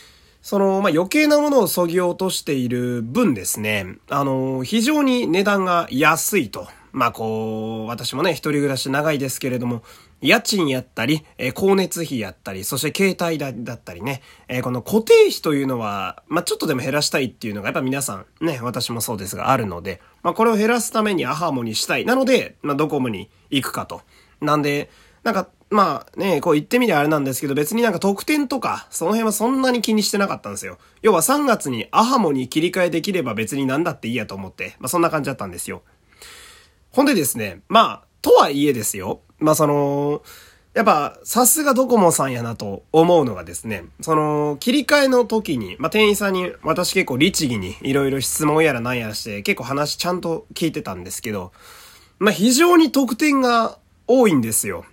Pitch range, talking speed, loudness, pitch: 125-200 Hz, 395 characters per minute, -19 LUFS, 150 Hz